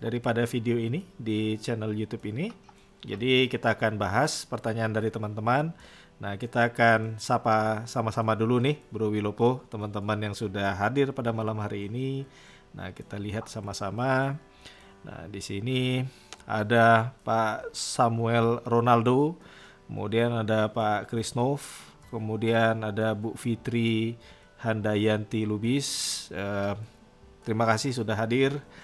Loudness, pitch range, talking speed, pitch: -27 LUFS, 110-125 Hz, 120 wpm, 115 Hz